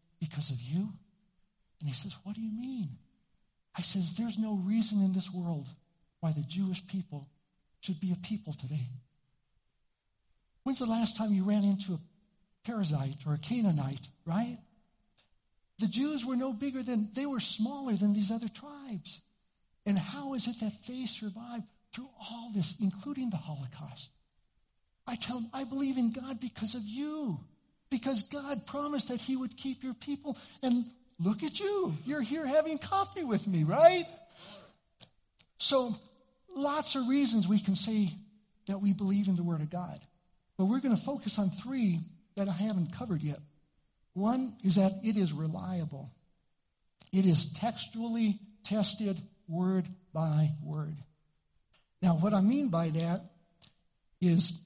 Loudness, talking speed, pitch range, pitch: -33 LUFS, 155 wpm, 175-245 Hz, 205 Hz